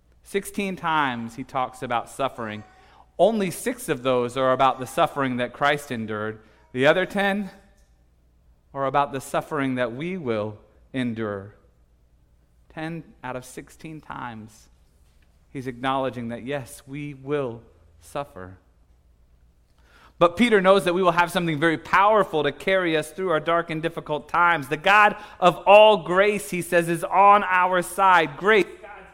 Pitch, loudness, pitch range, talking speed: 140 Hz, -22 LUFS, 110-175 Hz, 145 wpm